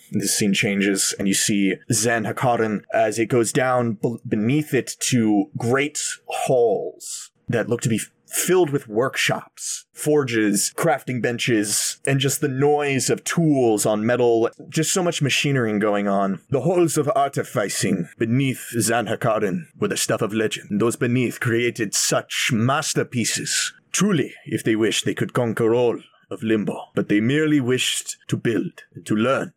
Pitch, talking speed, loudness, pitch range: 120 Hz, 160 wpm, -21 LUFS, 110-145 Hz